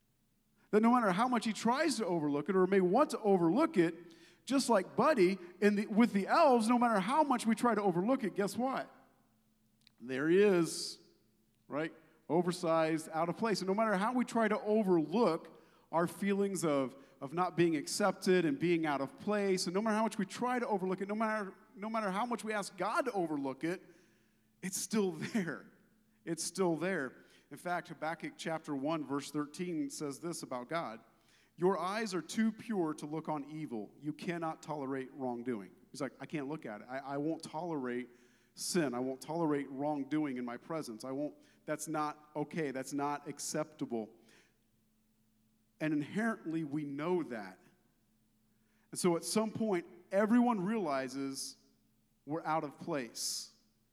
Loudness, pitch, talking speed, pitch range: -35 LUFS, 165 Hz, 175 wpm, 140-200 Hz